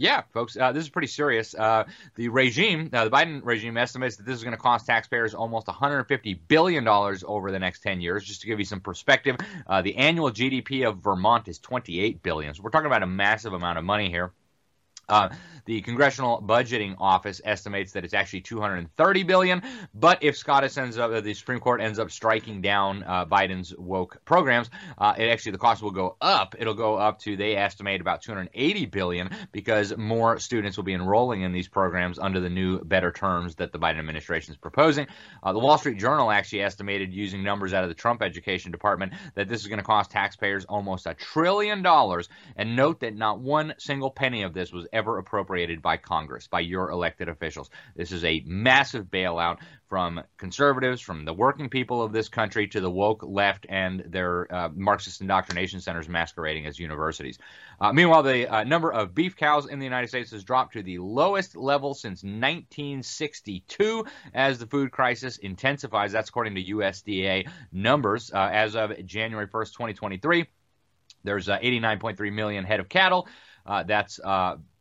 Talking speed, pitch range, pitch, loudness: 190 wpm, 95-130 Hz, 105 Hz, -25 LUFS